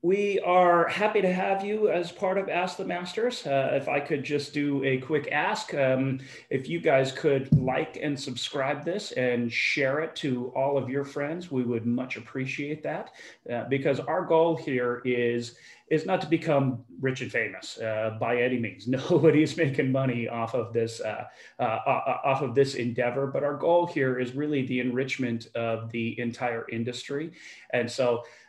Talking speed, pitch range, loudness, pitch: 185 wpm, 125-160 Hz, -27 LUFS, 135 Hz